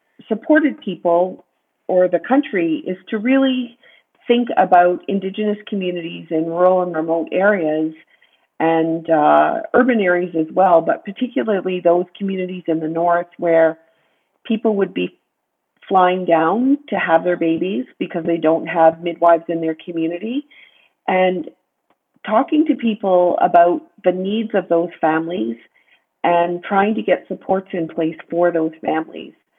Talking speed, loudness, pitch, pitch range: 140 wpm, -18 LUFS, 180 Hz, 165-210 Hz